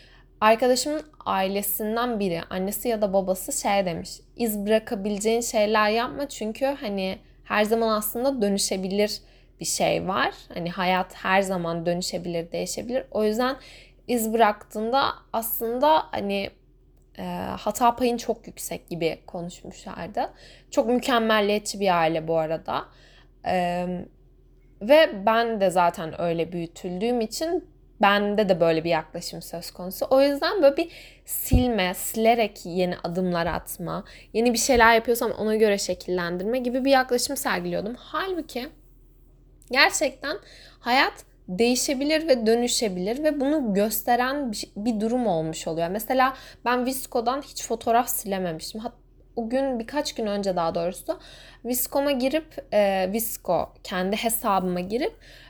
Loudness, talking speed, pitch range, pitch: -24 LUFS, 125 wpm, 185-250 Hz, 220 Hz